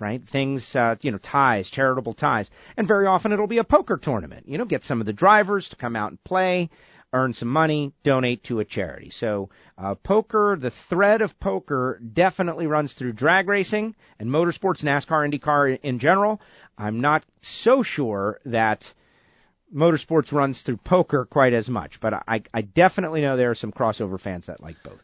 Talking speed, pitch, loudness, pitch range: 185 wpm, 140 Hz, -22 LUFS, 115-185 Hz